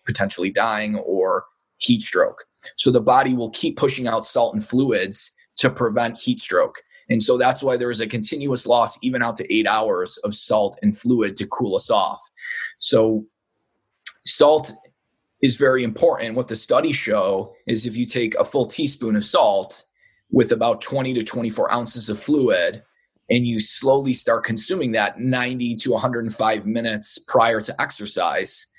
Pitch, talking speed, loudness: 120 Hz, 165 wpm, -21 LUFS